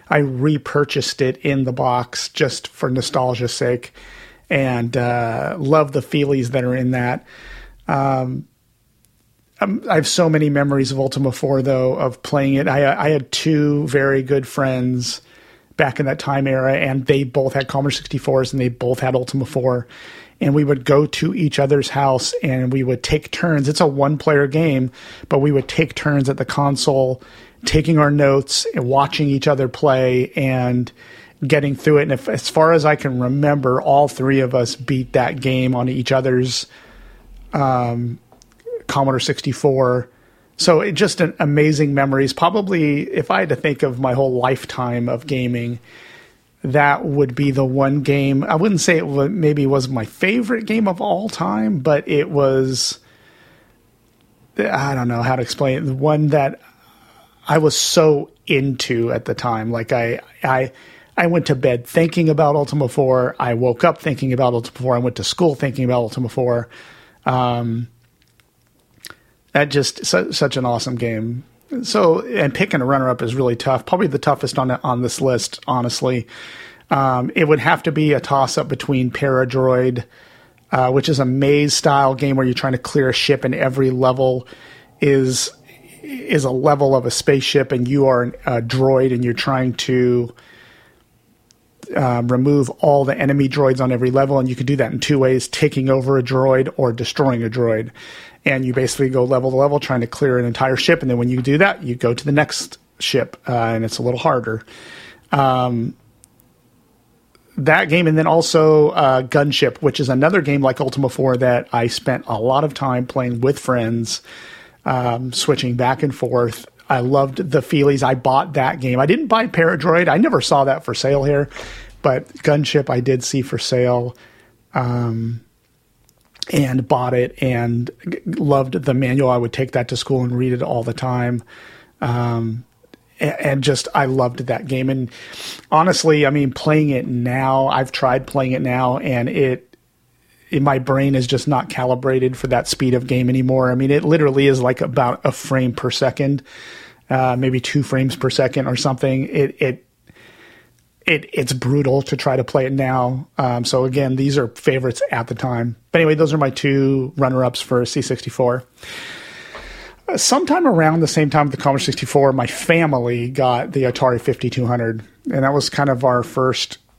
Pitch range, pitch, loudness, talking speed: 125-145 Hz, 130 Hz, -17 LUFS, 180 wpm